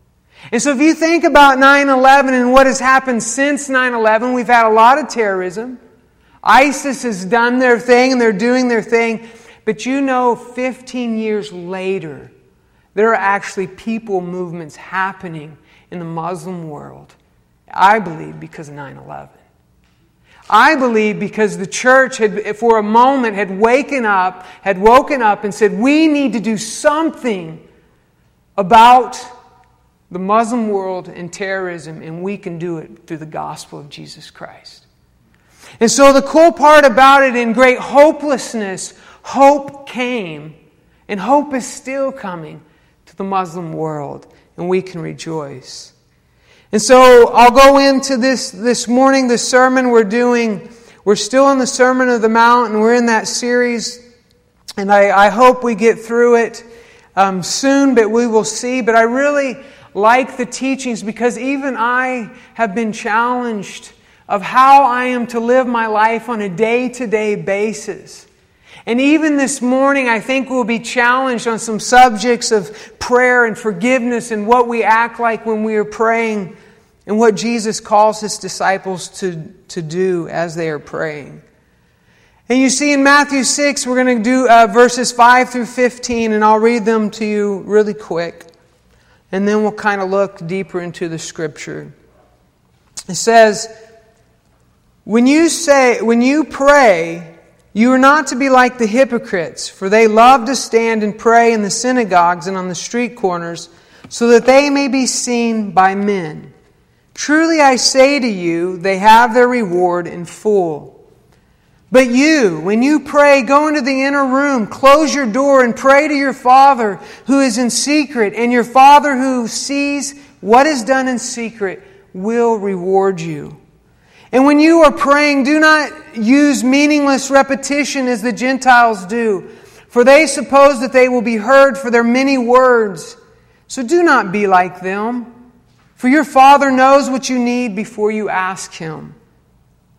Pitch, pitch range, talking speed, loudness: 235 Hz, 200-260 Hz, 160 wpm, -12 LUFS